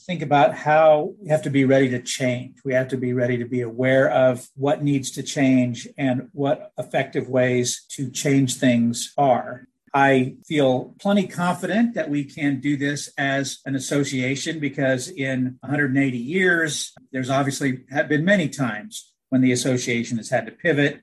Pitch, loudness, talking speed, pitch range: 135 Hz, -21 LUFS, 170 wpm, 125-145 Hz